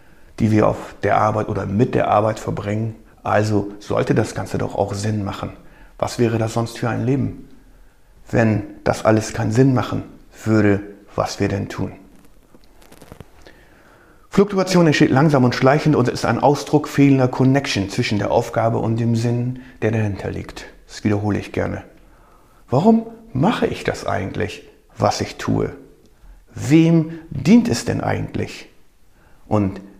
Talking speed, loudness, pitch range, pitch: 150 wpm, -19 LUFS, 105-135 Hz, 115 Hz